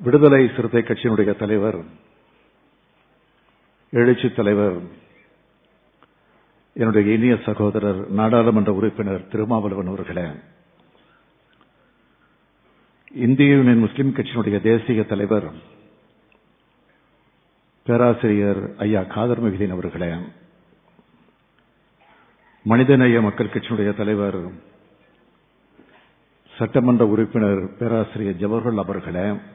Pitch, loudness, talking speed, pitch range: 110 Hz, -19 LUFS, 65 wpm, 100-120 Hz